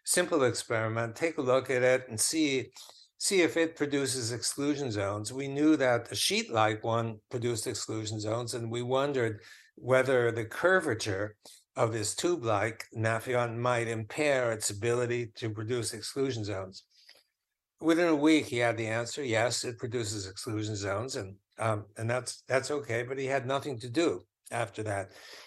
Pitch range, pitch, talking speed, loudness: 110-135 Hz, 120 Hz, 165 wpm, -30 LUFS